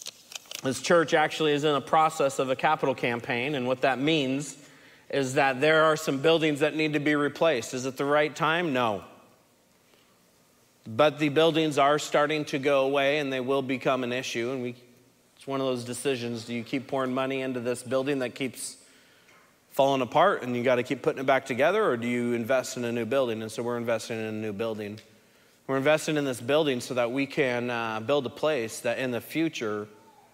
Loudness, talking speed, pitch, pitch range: -26 LUFS, 210 wpm, 135 Hz, 120-150 Hz